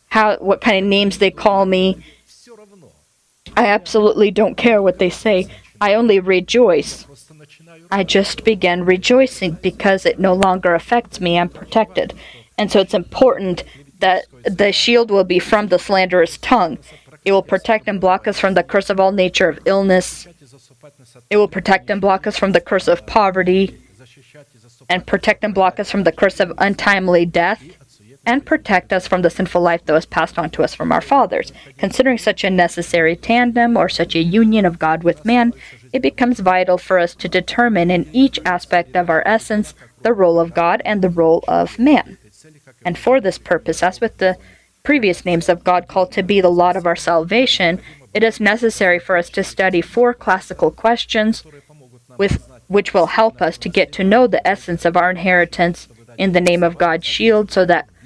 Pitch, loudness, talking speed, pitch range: 185 Hz, -15 LUFS, 185 wpm, 170-210 Hz